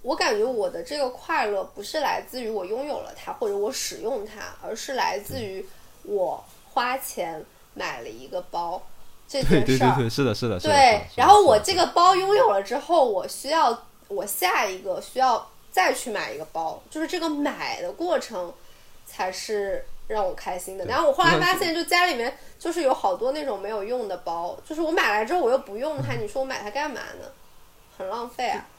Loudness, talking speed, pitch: -24 LUFS, 290 characters per minute, 270 Hz